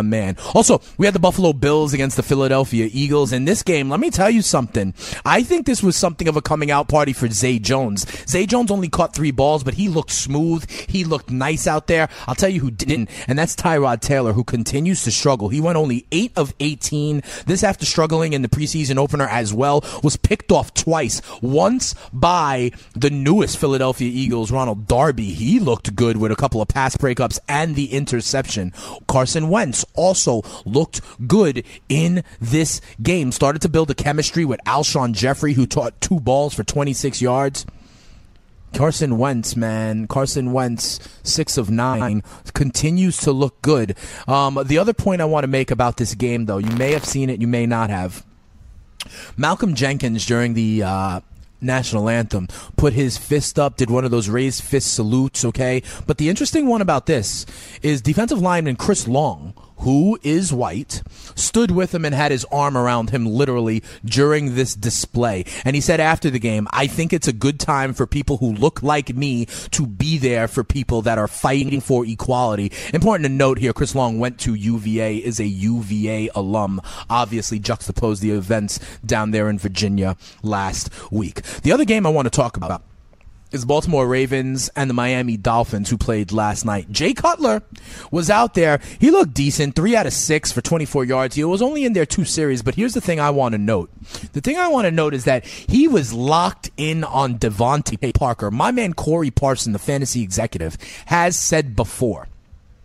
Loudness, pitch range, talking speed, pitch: -19 LUFS, 115-150 Hz, 190 wpm, 135 Hz